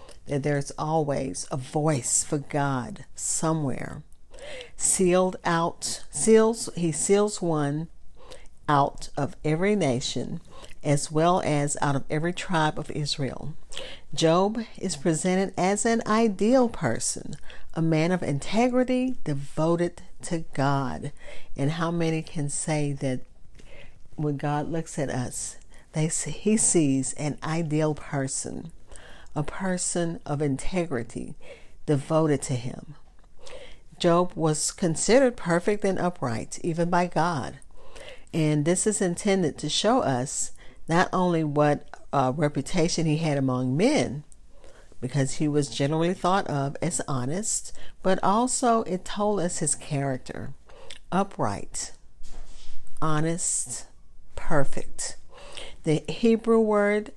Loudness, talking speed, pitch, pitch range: -26 LUFS, 120 wpm, 160 Hz, 145-185 Hz